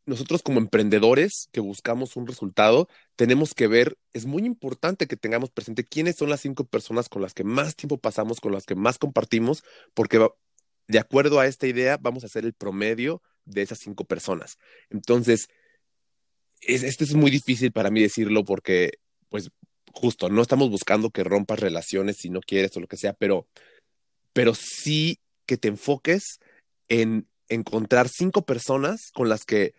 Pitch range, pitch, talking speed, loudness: 110-140 Hz, 120 Hz, 170 wpm, -24 LUFS